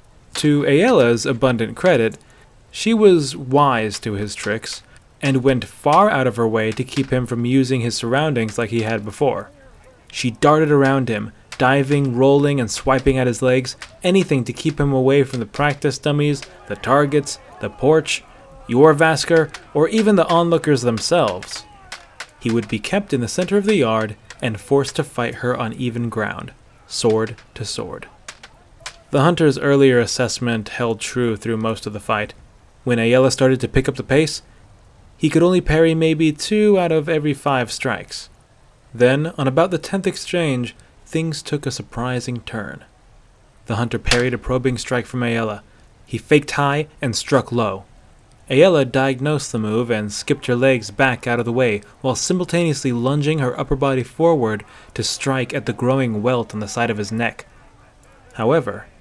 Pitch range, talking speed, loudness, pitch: 115-145 Hz, 170 wpm, -18 LUFS, 130 Hz